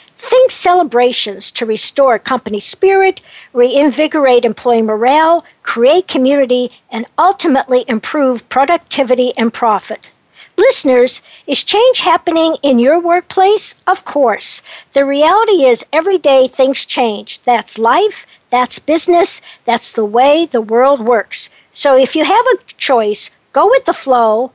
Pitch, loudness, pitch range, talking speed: 275 Hz, -12 LUFS, 240-345 Hz, 130 wpm